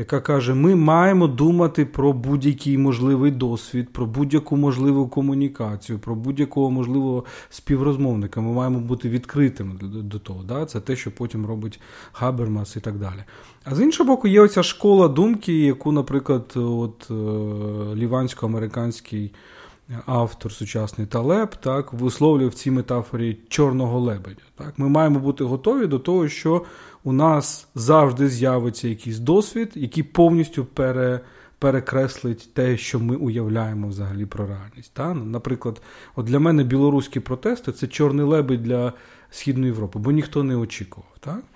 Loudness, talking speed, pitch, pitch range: -21 LUFS, 140 wpm, 130 Hz, 115-145 Hz